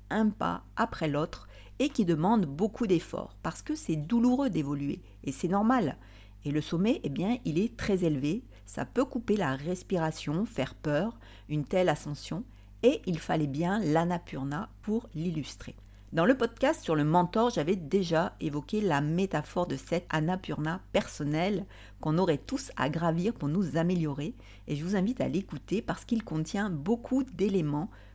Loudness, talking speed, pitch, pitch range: -30 LUFS, 165 wpm, 175 Hz, 150-205 Hz